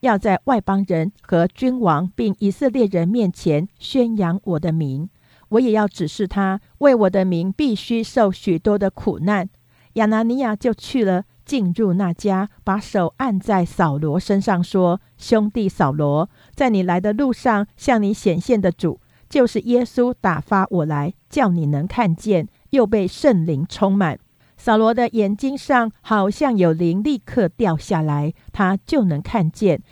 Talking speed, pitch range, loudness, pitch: 225 characters per minute, 175-225 Hz, -19 LUFS, 195 Hz